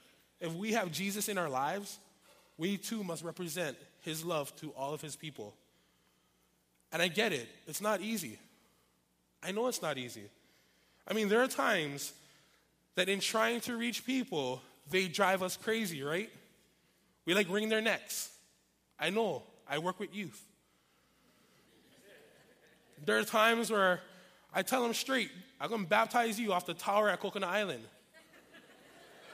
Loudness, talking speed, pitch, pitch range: -34 LUFS, 155 wpm, 185 Hz, 140-210 Hz